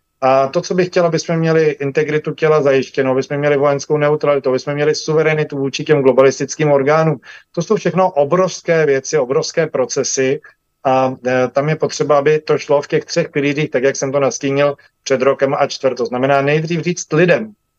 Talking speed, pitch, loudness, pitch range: 180 wpm, 145 Hz, -15 LUFS, 140-160 Hz